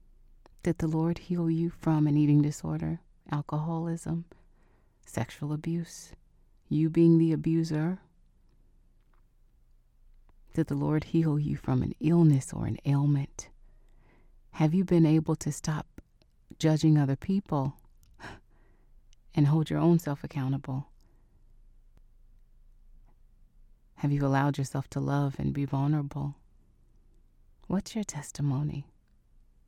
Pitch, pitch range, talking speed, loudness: 150 Hz, 135-160 Hz, 110 wpm, -29 LUFS